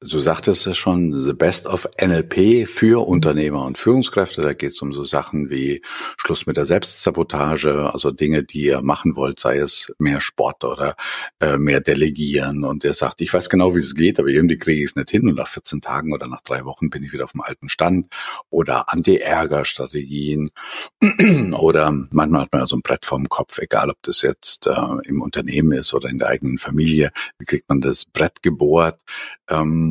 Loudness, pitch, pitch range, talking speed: -18 LUFS, 75 Hz, 70-85 Hz, 200 wpm